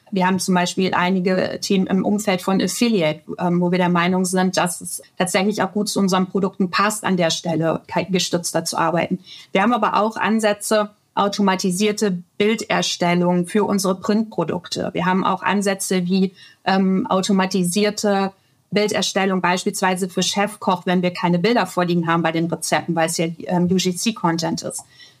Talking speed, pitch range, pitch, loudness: 155 wpm, 175-200 Hz, 185 Hz, -20 LUFS